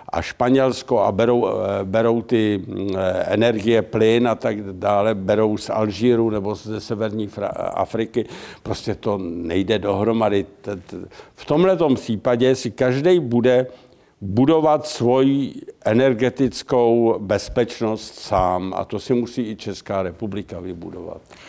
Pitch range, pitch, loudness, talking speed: 105-125 Hz, 115 Hz, -20 LUFS, 115 wpm